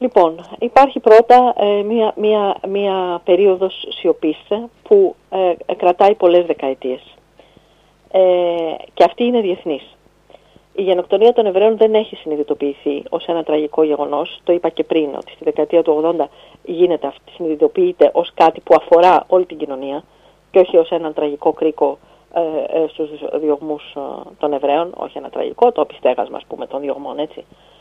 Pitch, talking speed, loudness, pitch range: 175 Hz, 150 wpm, -16 LUFS, 155-205 Hz